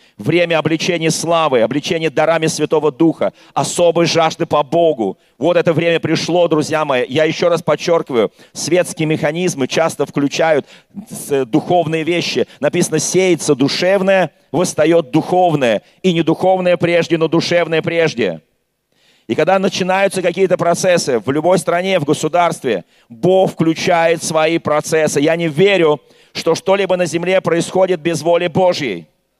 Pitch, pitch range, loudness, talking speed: 170 Hz, 155-180 Hz, -15 LUFS, 130 wpm